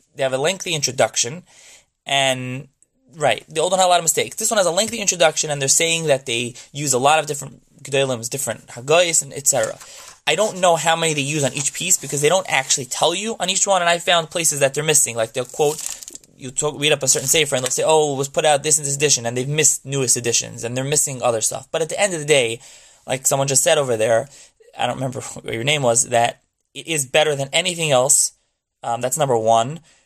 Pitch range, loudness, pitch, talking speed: 130-160 Hz, -18 LUFS, 145 Hz, 250 wpm